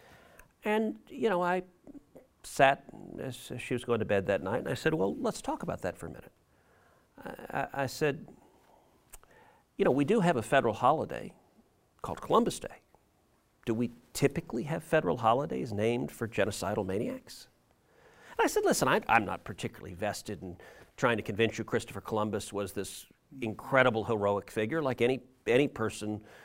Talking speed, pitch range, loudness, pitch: 170 wpm, 105-150 Hz, -31 LUFS, 120 Hz